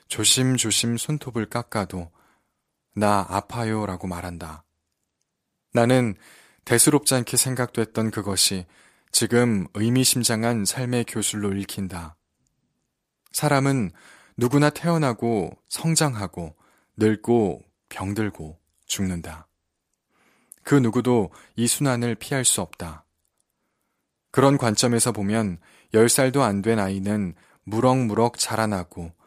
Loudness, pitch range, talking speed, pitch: -22 LUFS, 95-120 Hz, 220 characters per minute, 110 Hz